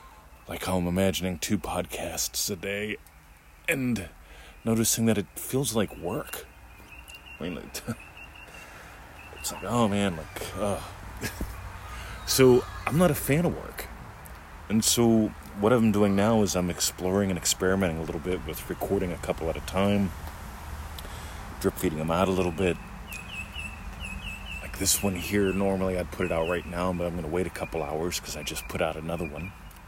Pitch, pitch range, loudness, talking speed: 90 Hz, 80-100 Hz, -27 LUFS, 175 wpm